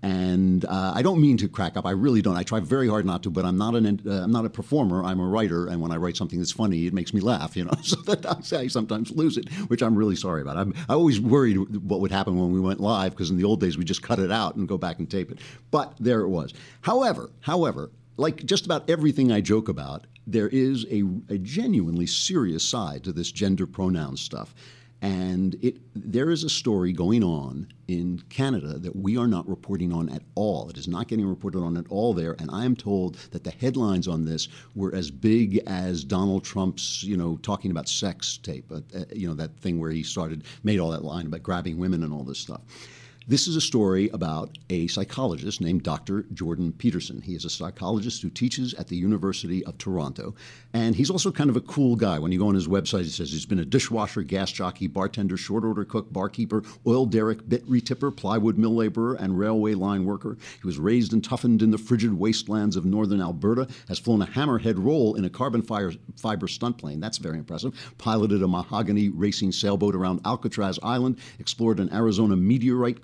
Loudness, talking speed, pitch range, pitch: -25 LUFS, 220 wpm, 90-120 Hz, 105 Hz